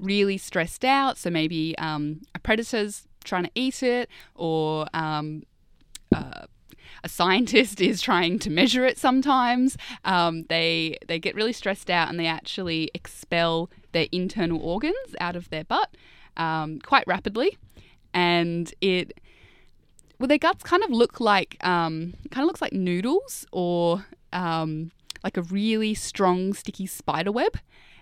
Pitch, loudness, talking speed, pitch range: 180 Hz, -25 LUFS, 150 wpm, 165-235 Hz